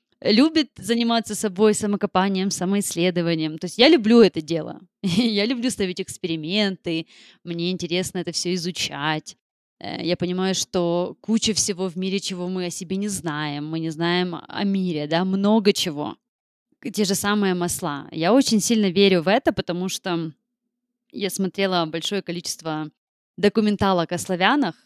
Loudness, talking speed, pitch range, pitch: -22 LUFS, 145 wpm, 175-210 Hz, 190 Hz